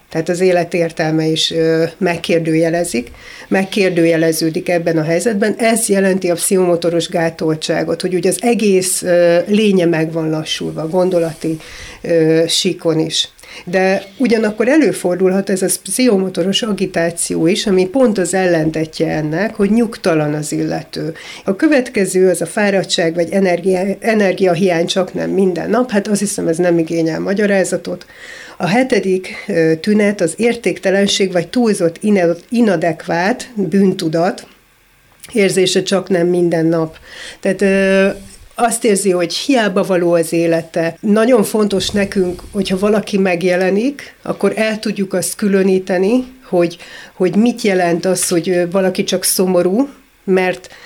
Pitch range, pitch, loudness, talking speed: 170-200 Hz, 185 Hz, -15 LUFS, 130 wpm